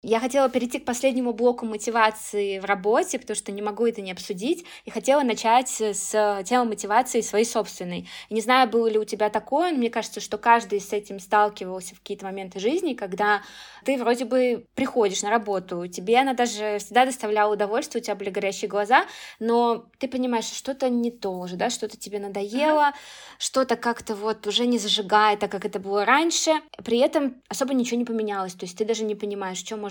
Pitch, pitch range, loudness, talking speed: 220 Hz, 205-250 Hz, -24 LUFS, 195 wpm